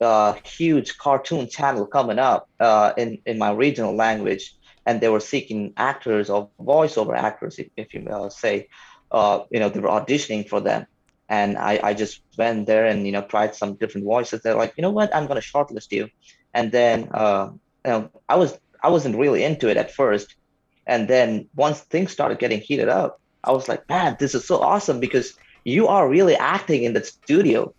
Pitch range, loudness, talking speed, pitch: 105-140 Hz, -21 LUFS, 205 wpm, 110 Hz